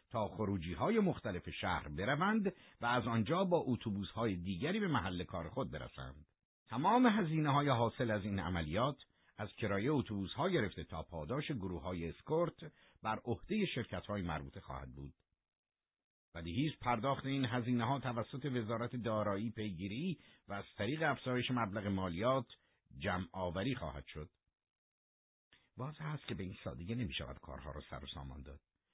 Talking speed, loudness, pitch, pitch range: 155 wpm, -38 LUFS, 105 Hz, 85-130 Hz